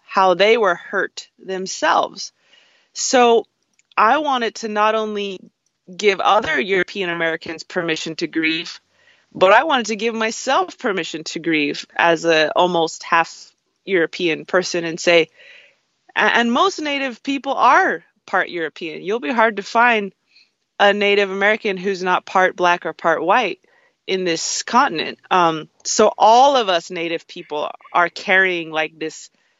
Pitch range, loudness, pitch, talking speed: 170-230 Hz, -18 LUFS, 190 Hz, 145 wpm